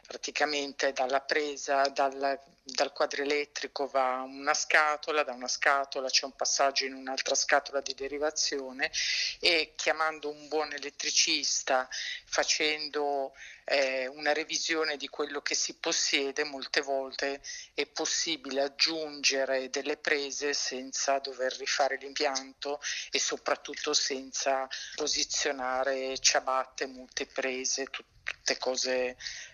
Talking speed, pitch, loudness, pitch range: 110 wpm, 140 Hz, -30 LUFS, 135-150 Hz